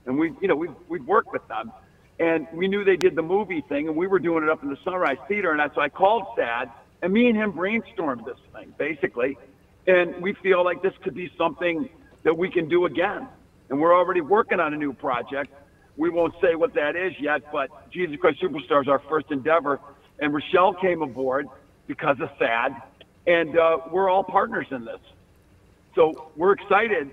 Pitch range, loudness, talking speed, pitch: 150-195 Hz, -23 LUFS, 205 wpm, 175 Hz